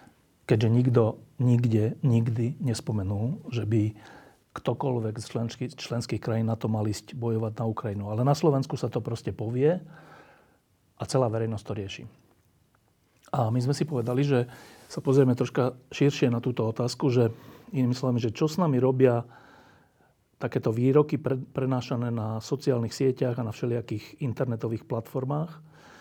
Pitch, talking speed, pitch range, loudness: 125 Hz, 150 wpm, 115-135 Hz, -27 LUFS